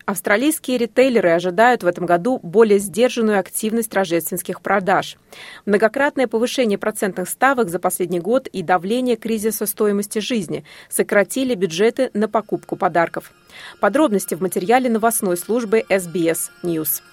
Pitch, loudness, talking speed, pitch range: 210 Hz, -19 LUFS, 125 wpm, 185-235 Hz